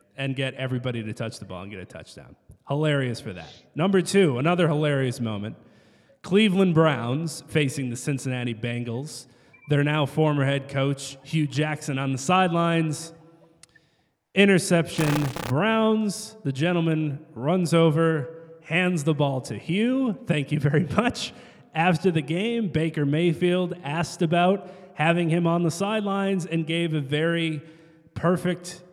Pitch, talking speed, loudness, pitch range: 160 Hz, 140 wpm, -24 LUFS, 135-175 Hz